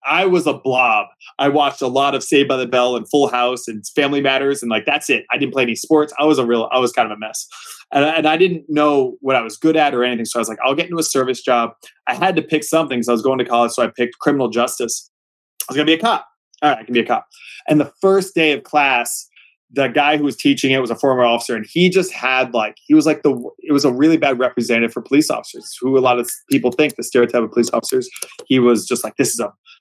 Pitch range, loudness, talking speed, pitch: 120-150 Hz, -17 LUFS, 290 wpm, 135 Hz